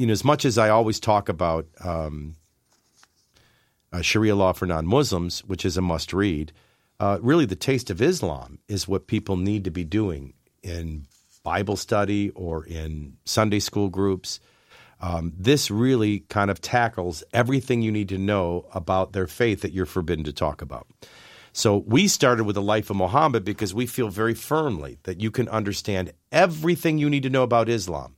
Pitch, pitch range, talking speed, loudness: 100 Hz, 90-115 Hz, 180 wpm, -23 LUFS